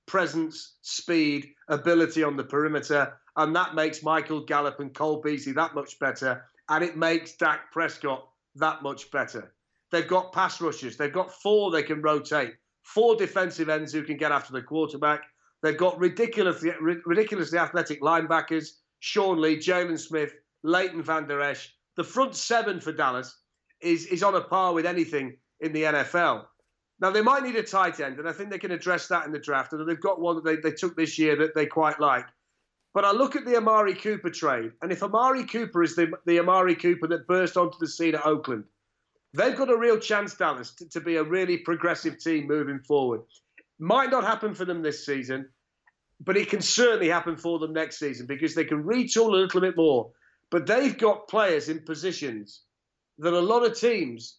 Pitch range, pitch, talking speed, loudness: 150-185 Hz, 165 Hz, 195 wpm, -26 LUFS